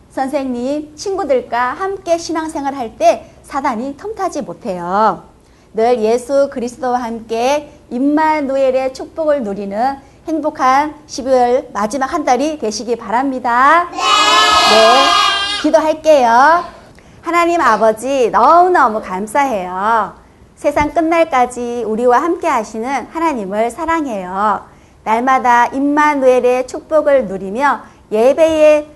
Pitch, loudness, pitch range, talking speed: 270 Hz, -14 LUFS, 240-315 Hz, 255 characters per minute